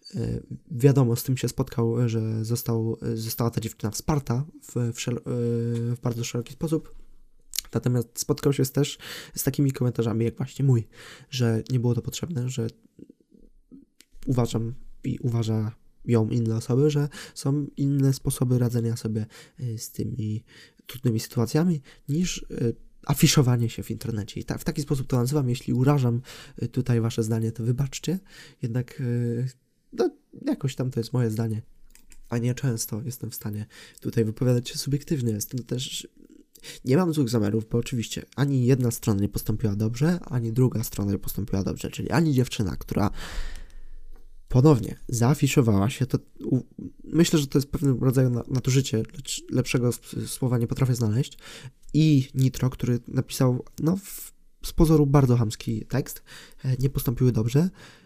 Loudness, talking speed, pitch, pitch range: -26 LUFS, 150 wpm, 125 Hz, 115-140 Hz